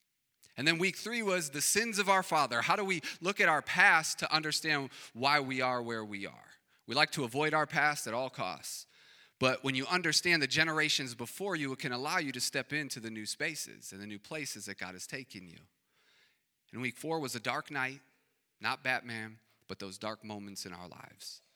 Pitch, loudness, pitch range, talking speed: 135 Hz, -32 LUFS, 115-155 Hz, 215 wpm